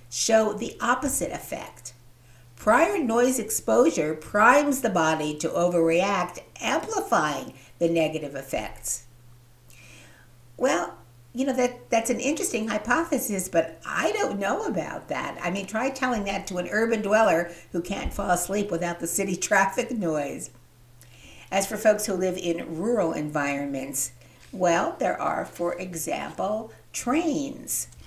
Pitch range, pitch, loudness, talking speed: 140-225 Hz, 175 Hz, -25 LUFS, 135 wpm